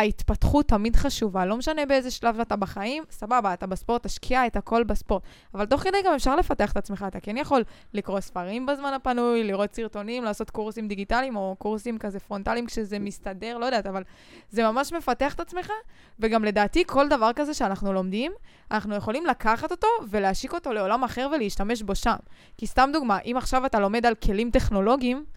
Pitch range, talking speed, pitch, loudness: 205-265 Hz, 185 wpm, 230 Hz, -26 LUFS